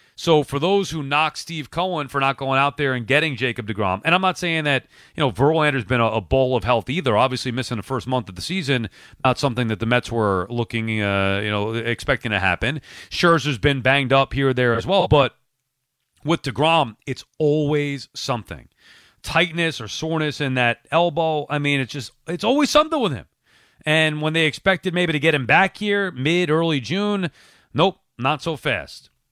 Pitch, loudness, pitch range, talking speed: 140 Hz, -20 LUFS, 125-160 Hz, 200 wpm